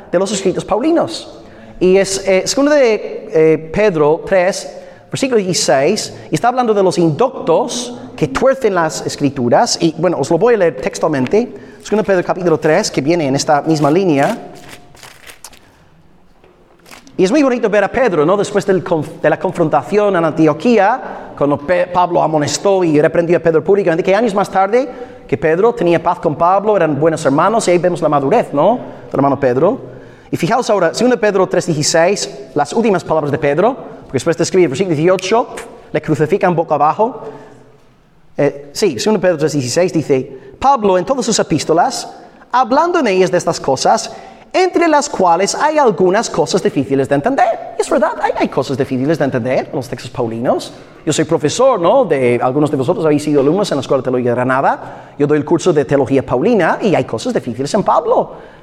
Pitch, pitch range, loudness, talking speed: 180 Hz, 150-215 Hz, -14 LUFS, 180 wpm